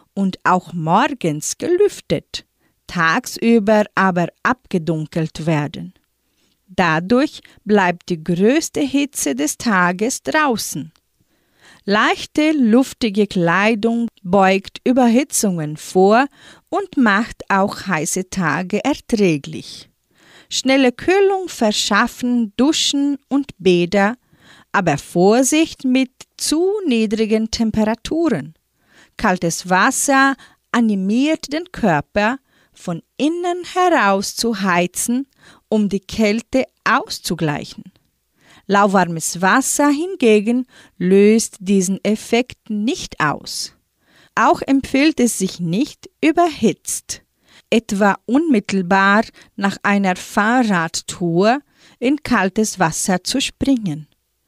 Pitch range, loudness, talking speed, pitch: 185-265 Hz, -17 LUFS, 85 wpm, 220 Hz